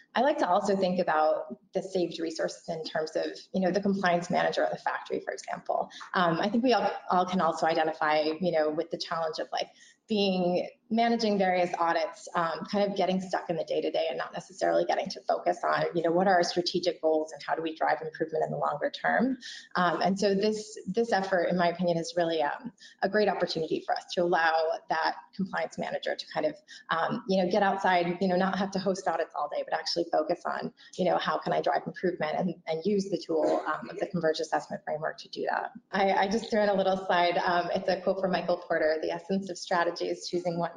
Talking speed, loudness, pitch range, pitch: 235 wpm, -29 LUFS, 170-200 Hz, 180 Hz